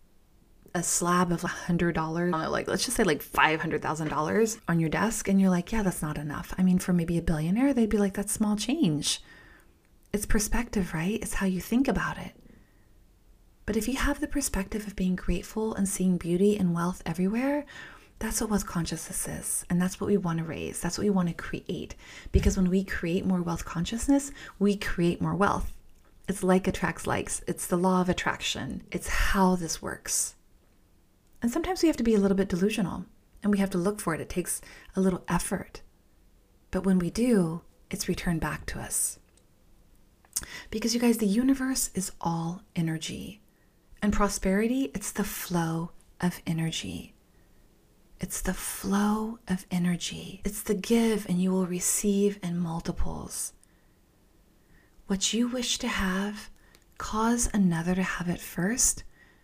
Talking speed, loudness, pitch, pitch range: 175 wpm, -28 LUFS, 190 Hz, 175-210 Hz